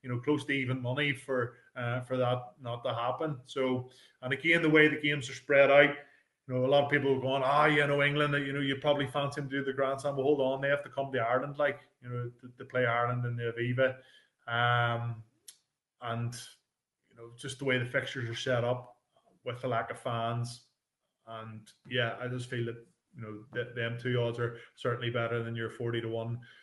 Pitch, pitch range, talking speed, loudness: 125 Hz, 120-140 Hz, 230 wpm, -31 LUFS